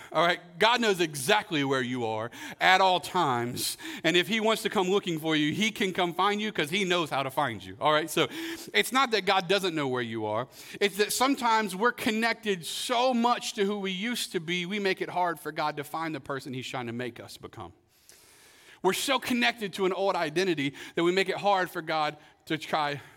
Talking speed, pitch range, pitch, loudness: 230 wpm, 150-210 Hz, 185 Hz, -27 LUFS